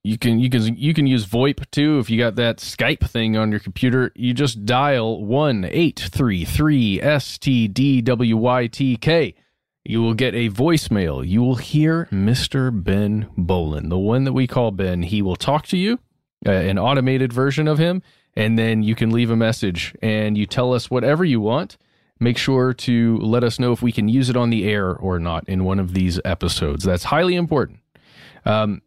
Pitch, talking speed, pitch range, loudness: 120 Hz, 205 wpm, 105-130 Hz, -19 LUFS